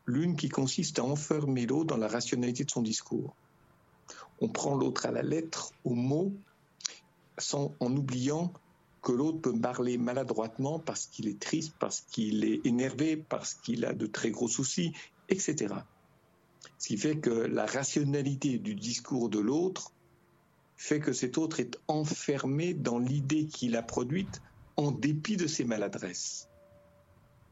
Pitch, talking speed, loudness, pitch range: 135 Hz, 155 wpm, -32 LUFS, 120-155 Hz